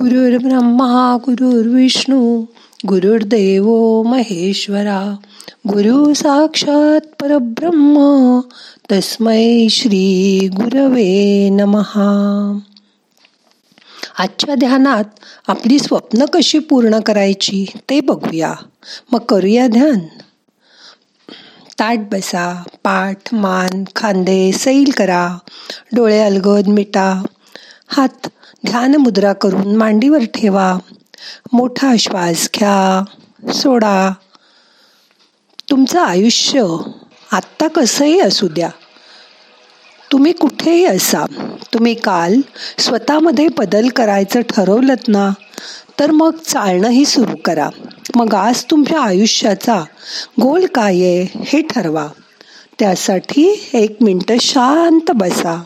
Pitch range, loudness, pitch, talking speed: 200-270 Hz, -13 LUFS, 230 Hz, 80 wpm